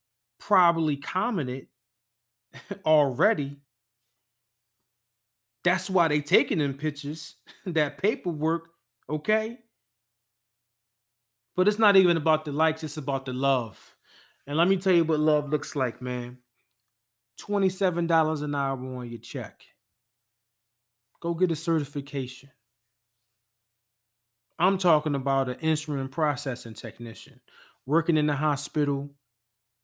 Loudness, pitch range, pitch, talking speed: -26 LUFS, 115-160 Hz, 135 Hz, 110 wpm